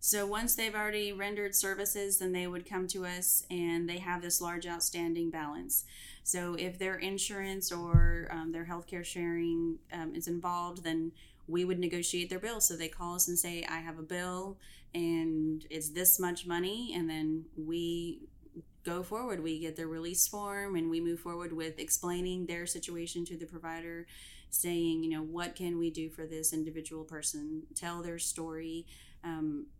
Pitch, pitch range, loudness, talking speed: 170 Hz, 165-180 Hz, -34 LUFS, 175 wpm